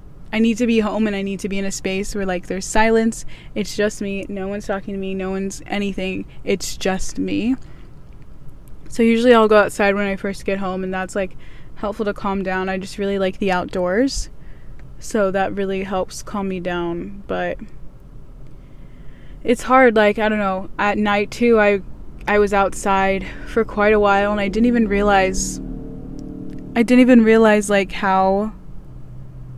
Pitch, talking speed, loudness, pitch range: 200 Hz, 185 wpm, -19 LUFS, 190-215 Hz